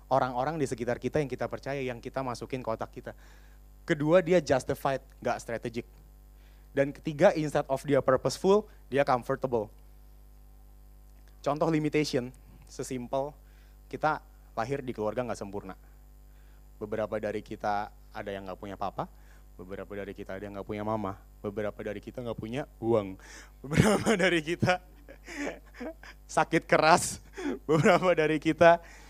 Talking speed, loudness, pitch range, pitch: 135 wpm, -29 LUFS, 105-145 Hz, 125 Hz